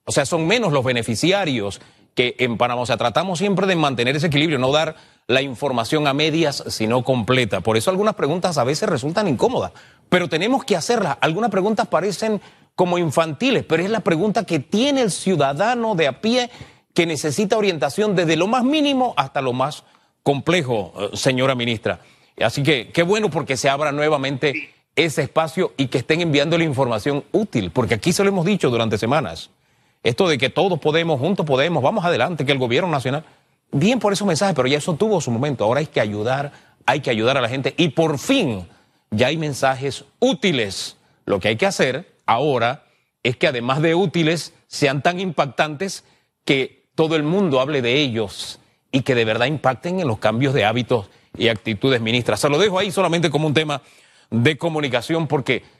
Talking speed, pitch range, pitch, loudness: 190 wpm, 130-180 Hz, 150 Hz, -19 LUFS